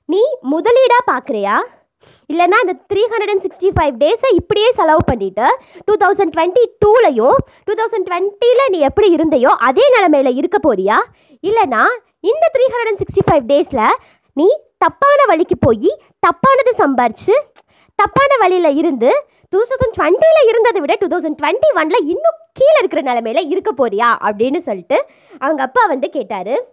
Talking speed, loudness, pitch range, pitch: 150 wpm, -13 LUFS, 315-445 Hz, 370 Hz